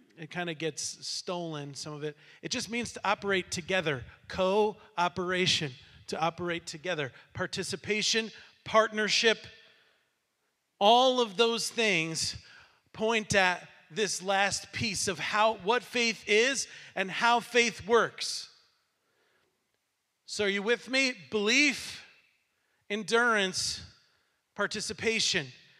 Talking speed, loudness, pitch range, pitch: 105 wpm, -29 LUFS, 175-225 Hz, 200 Hz